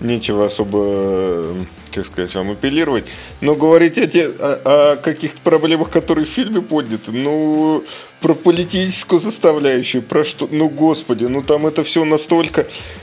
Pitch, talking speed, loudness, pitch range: 150 Hz, 145 wpm, -16 LUFS, 120-165 Hz